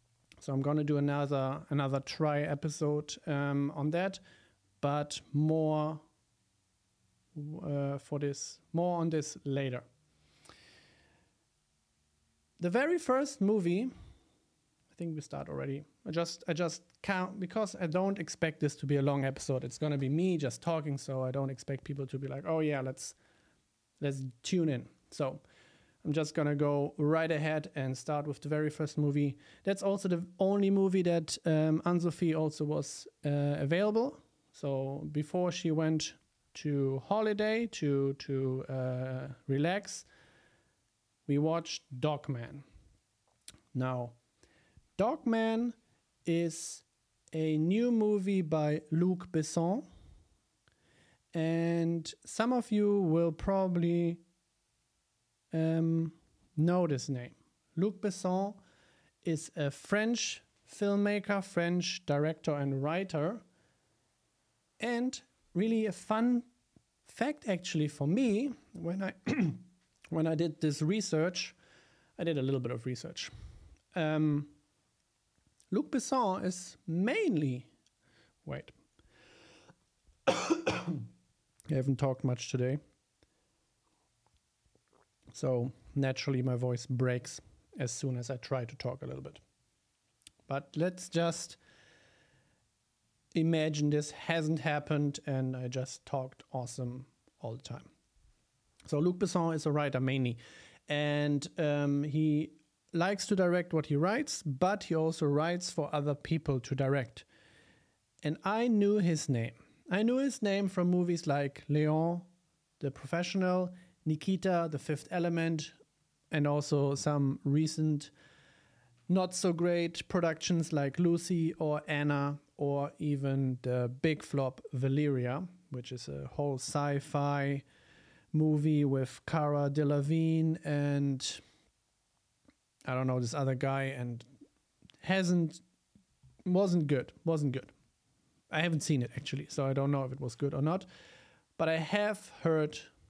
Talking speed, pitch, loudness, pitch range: 125 wpm, 150 Hz, -33 LUFS, 140-175 Hz